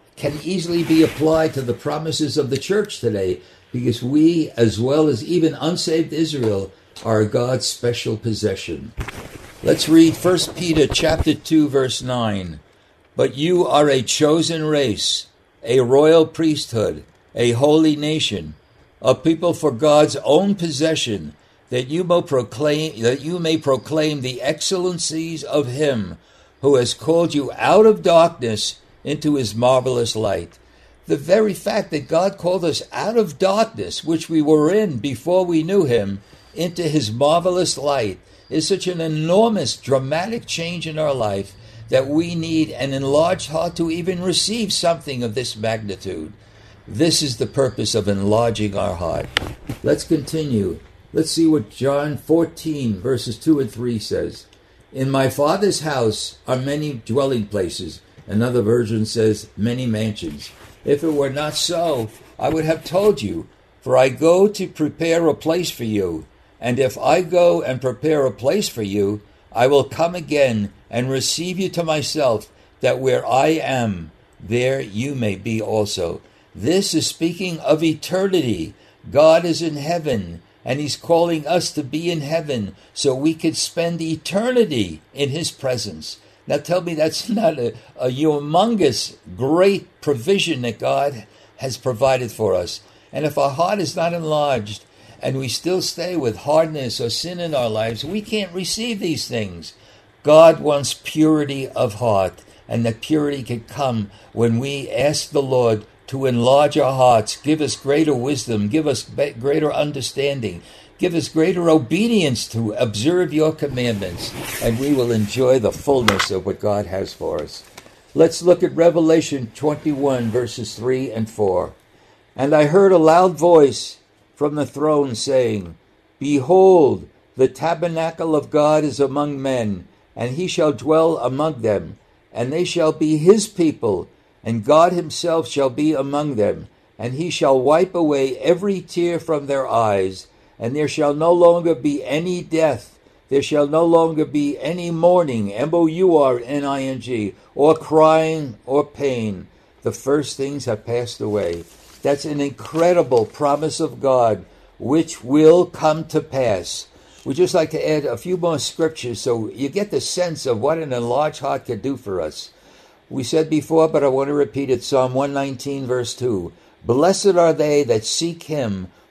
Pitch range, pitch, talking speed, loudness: 120-160 Hz, 145 Hz, 160 wpm, -19 LUFS